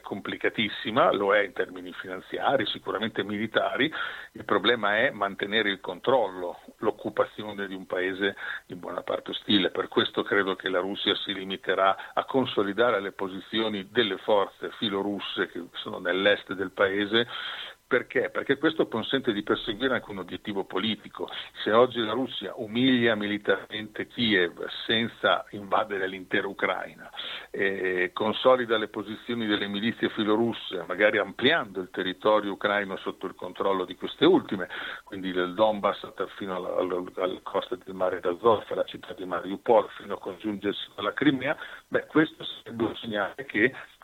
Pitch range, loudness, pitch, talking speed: 95-110 Hz, -27 LUFS, 105 Hz, 145 wpm